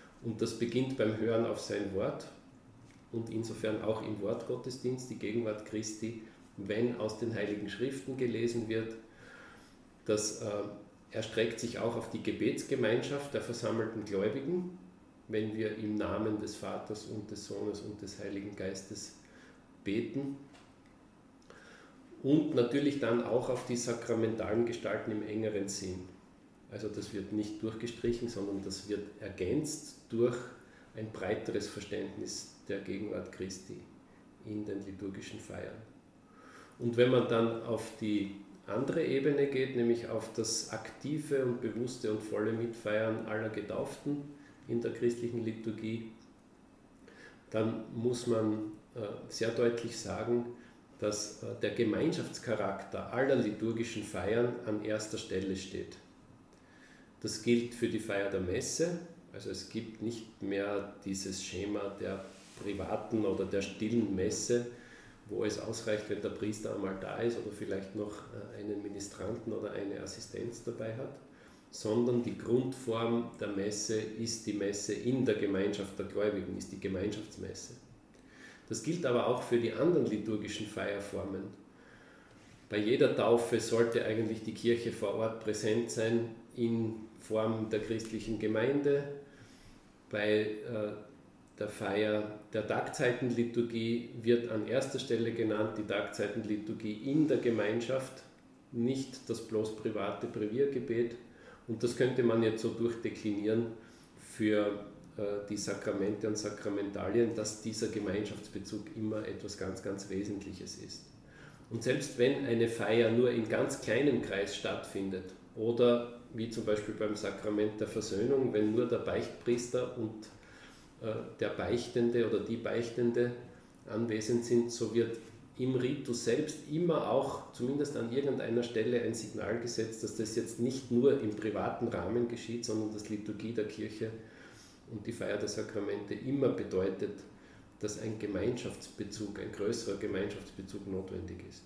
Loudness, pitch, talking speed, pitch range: -35 LUFS, 110 Hz, 135 wpm, 105-120 Hz